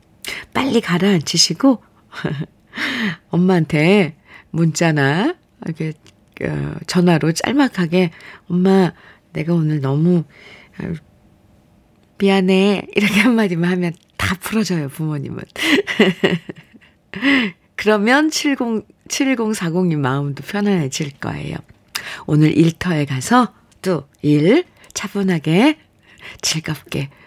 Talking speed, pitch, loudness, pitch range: 185 characters per minute, 180 Hz, -17 LUFS, 155-205 Hz